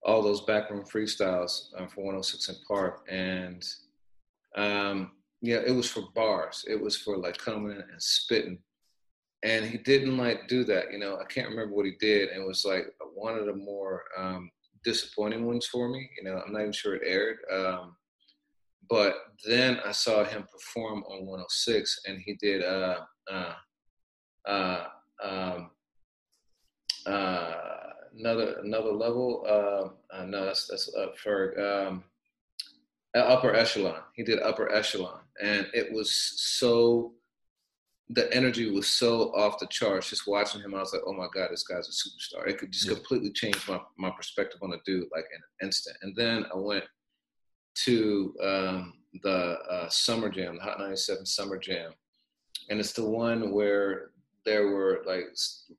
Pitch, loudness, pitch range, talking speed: 105 Hz, -29 LUFS, 95-115 Hz, 170 wpm